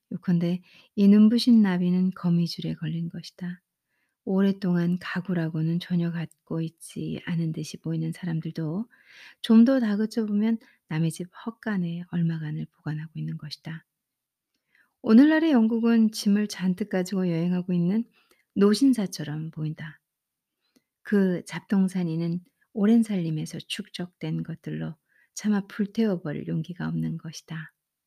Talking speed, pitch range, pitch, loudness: 280 characters per minute, 165-210 Hz, 180 Hz, -25 LUFS